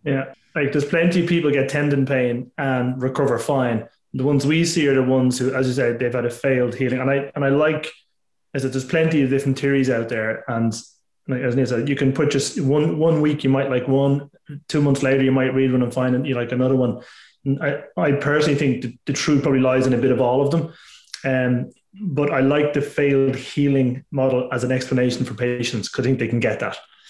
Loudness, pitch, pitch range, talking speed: -20 LUFS, 135 Hz, 125-145 Hz, 245 wpm